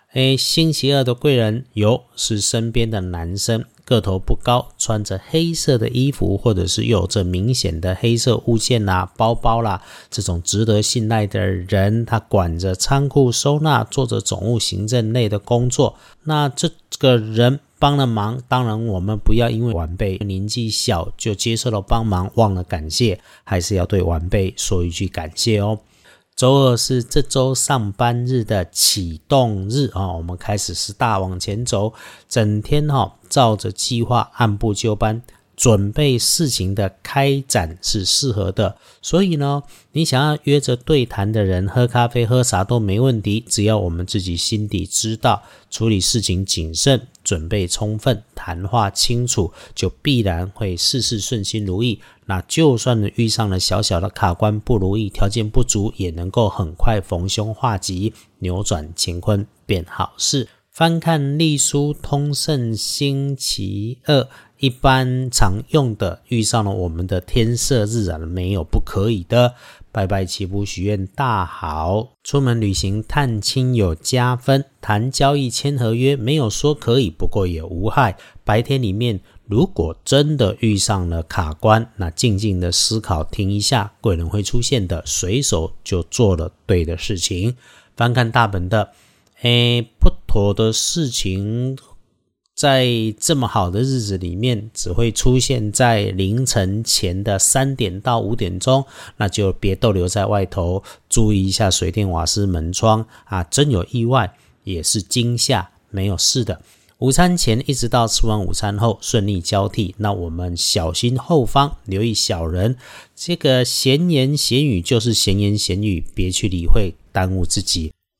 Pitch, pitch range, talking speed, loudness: 110 Hz, 95-125 Hz, 230 characters per minute, -18 LUFS